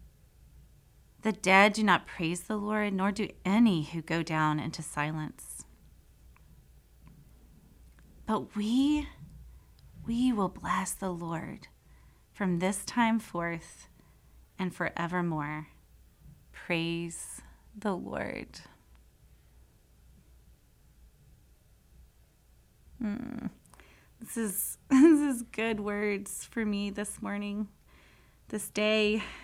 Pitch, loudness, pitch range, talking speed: 195 Hz, -30 LUFS, 160-215 Hz, 90 wpm